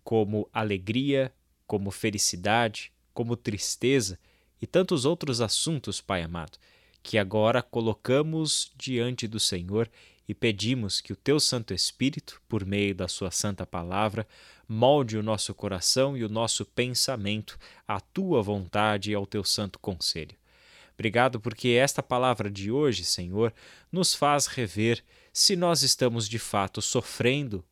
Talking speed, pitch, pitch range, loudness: 135 wpm, 115 Hz, 100-130 Hz, -27 LUFS